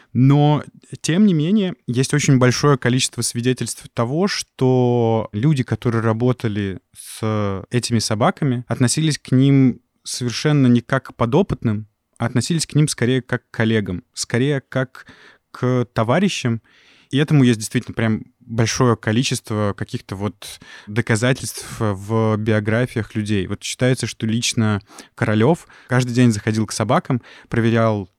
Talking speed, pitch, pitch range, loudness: 130 wpm, 120 Hz, 110-130 Hz, -19 LUFS